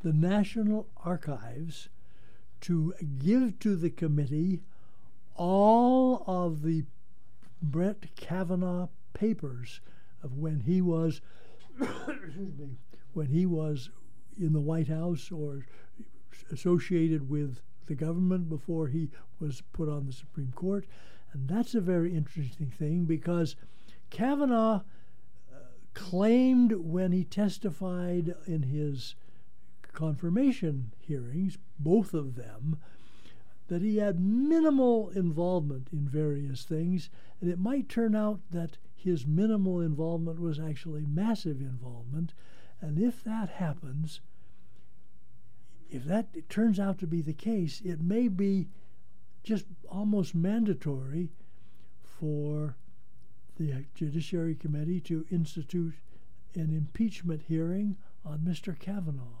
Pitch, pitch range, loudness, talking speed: 165 Hz, 145-185 Hz, -31 LUFS, 110 wpm